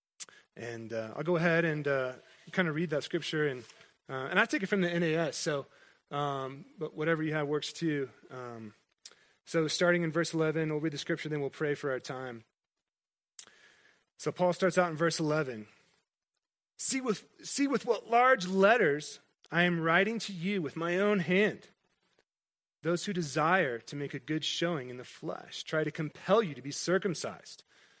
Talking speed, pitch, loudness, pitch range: 185 wpm, 160 Hz, -31 LUFS, 145-180 Hz